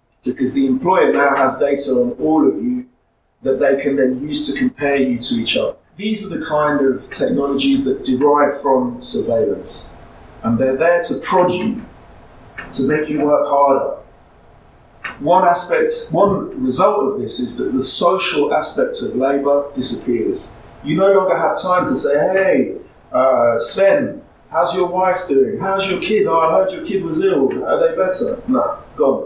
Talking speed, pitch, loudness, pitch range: 175 wpm, 150 Hz, -16 LUFS, 135-205 Hz